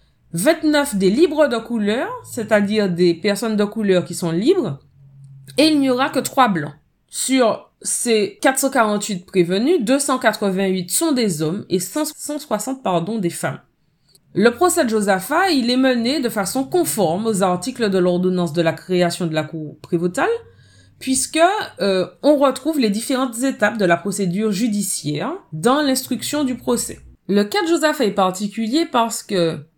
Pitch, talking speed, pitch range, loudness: 220 Hz, 155 wpm, 180-265 Hz, -19 LUFS